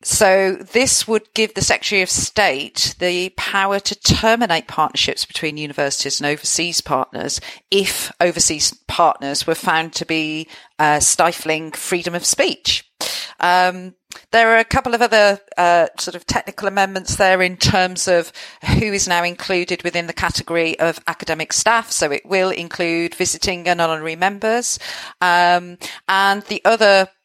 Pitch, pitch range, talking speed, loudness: 180 Hz, 165-200 Hz, 150 wpm, -17 LUFS